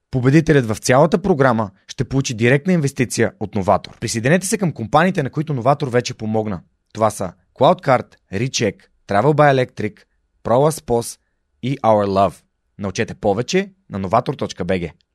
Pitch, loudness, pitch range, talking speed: 125 Hz, -18 LUFS, 105-145 Hz, 135 wpm